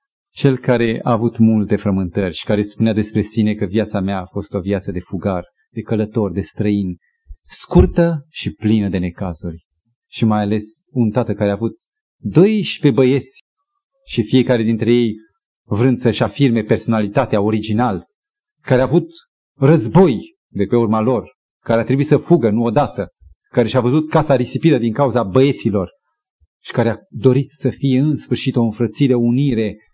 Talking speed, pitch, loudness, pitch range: 165 wpm, 115 Hz, -17 LUFS, 105-135 Hz